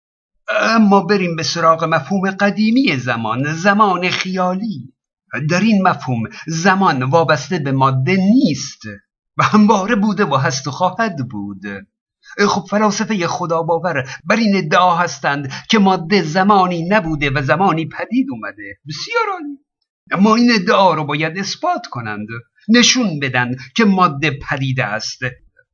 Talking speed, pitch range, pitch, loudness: 130 wpm, 150-210 Hz, 180 Hz, -15 LUFS